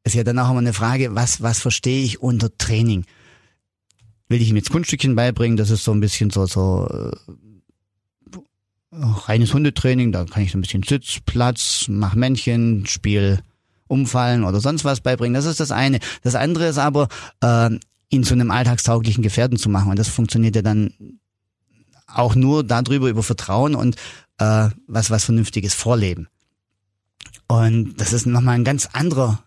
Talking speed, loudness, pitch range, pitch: 170 wpm, -19 LUFS, 105-125 Hz, 115 Hz